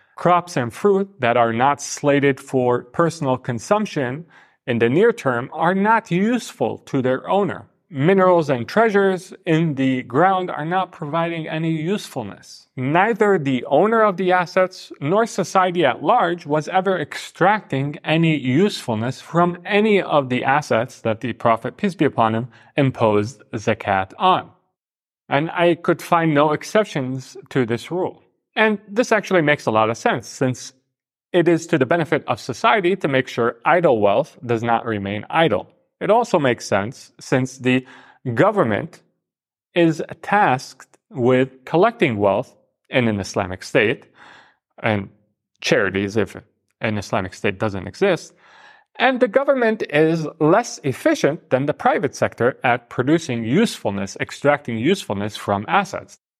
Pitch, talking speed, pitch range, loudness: 145 Hz, 145 wpm, 120-185 Hz, -19 LUFS